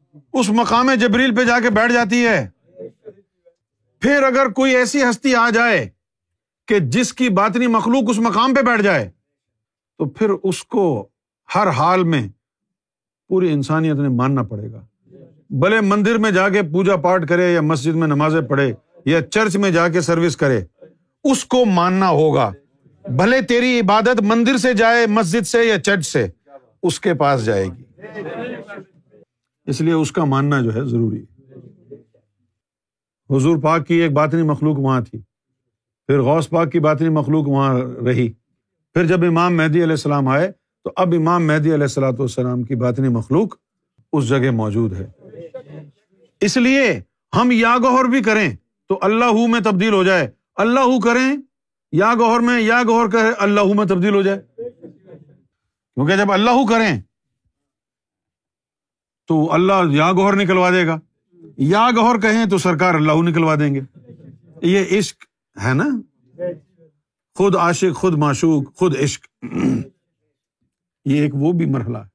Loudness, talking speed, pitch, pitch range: -16 LUFS, 155 wpm, 170 Hz, 140-220 Hz